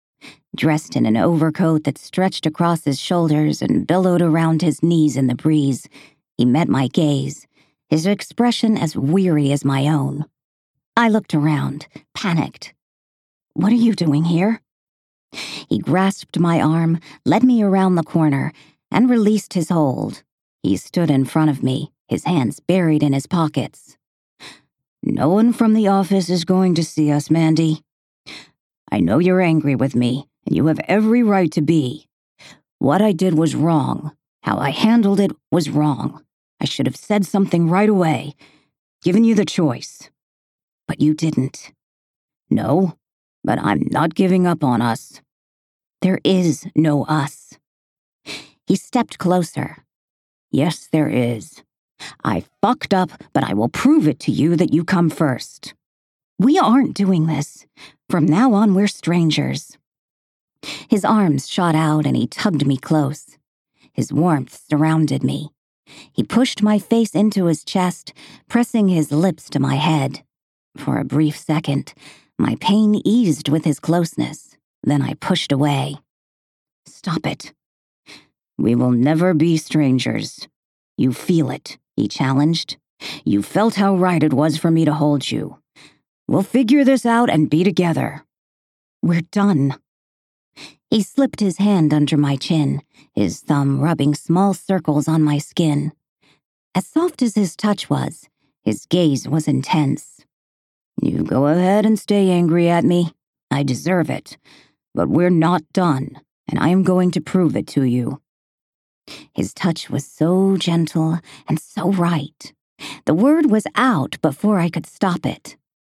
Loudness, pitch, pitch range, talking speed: -18 LUFS, 160 Hz, 145-185 Hz, 150 wpm